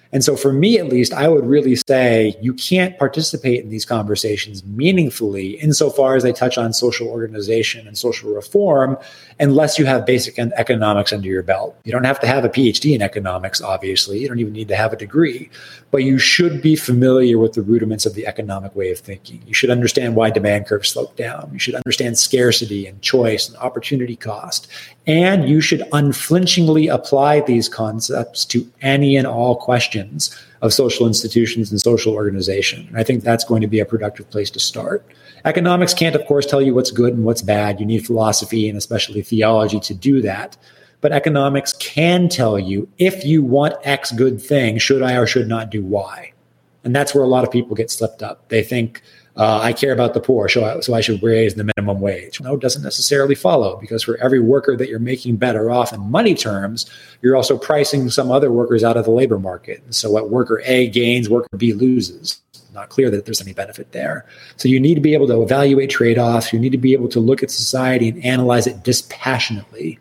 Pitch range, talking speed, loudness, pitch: 110-135 Hz, 210 wpm, -16 LUFS, 120 Hz